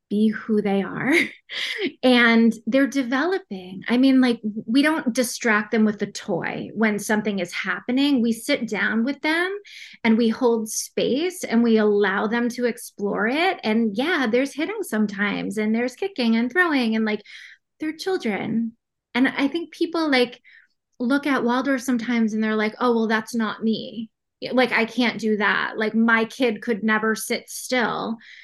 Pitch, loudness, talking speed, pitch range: 235 Hz, -22 LUFS, 170 wpm, 220-260 Hz